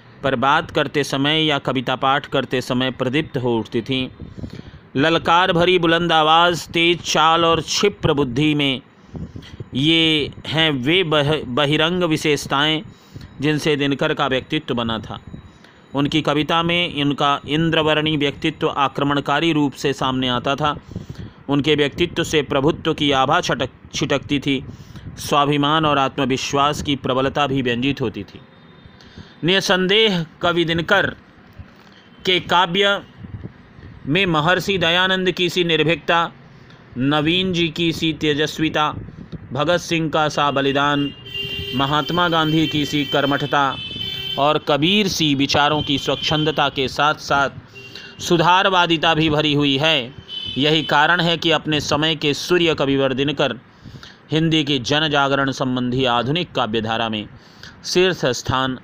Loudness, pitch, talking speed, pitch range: -18 LUFS, 150 Hz, 125 wpm, 135-160 Hz